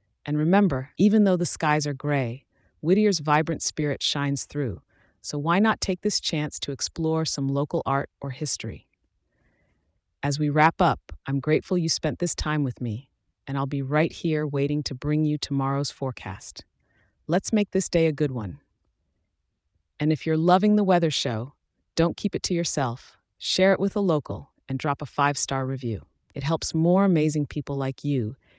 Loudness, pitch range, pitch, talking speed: -25 LUFS, 130-165 Hz, 145 Hz, 180 wpm